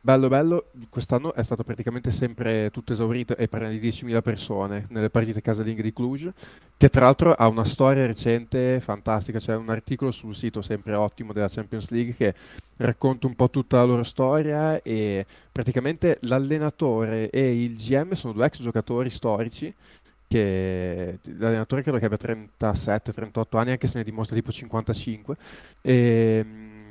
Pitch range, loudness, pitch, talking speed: 110-130 Hz, -24 LUFS, 115 Hz, 155 wpm